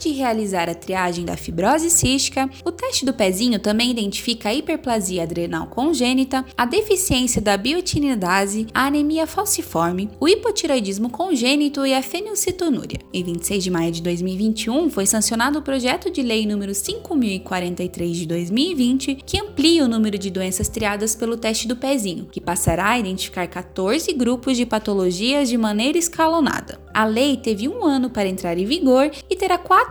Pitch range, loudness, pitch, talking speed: 200-295 Hz, -20 LUFS, 245 Hz, 160 wpm